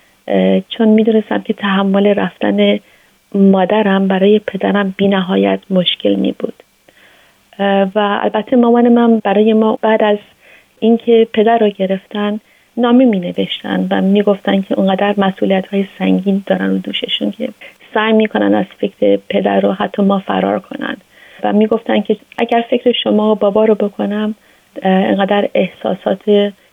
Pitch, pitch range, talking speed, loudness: 205 Hz, 190-220 Hz, 145 wpm, -14 LUFS